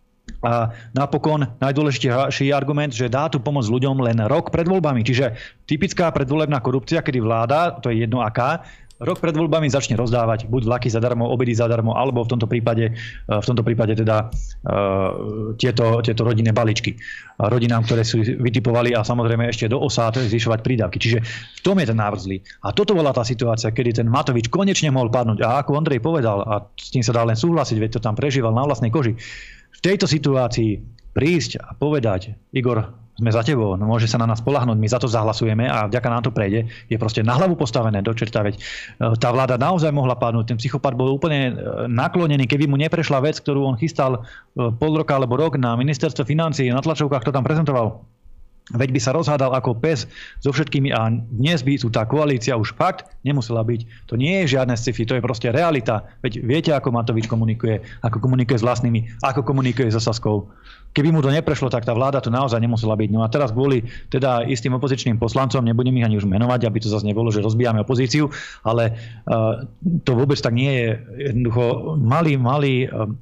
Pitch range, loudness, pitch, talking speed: 115-140 Hz, -20 LUFS, 125 Hz, 195 wpm